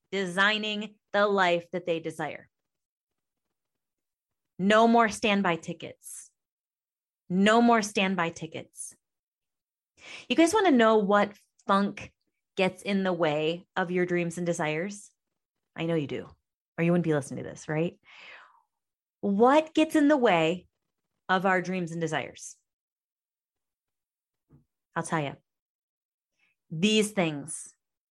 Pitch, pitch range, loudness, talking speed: 185 Hz, 165-210 Hz, -26 LUFS, 120 wpm